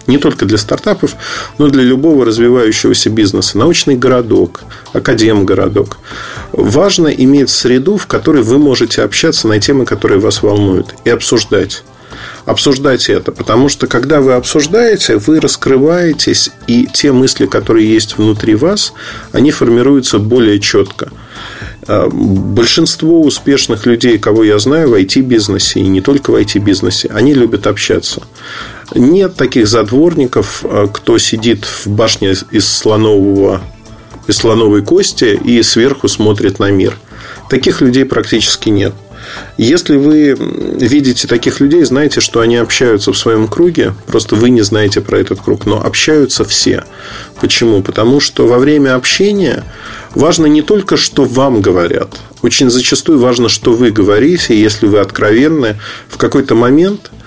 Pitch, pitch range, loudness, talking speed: 125 Hz, 110-145 Hz, -9 LUFS, 135 wpm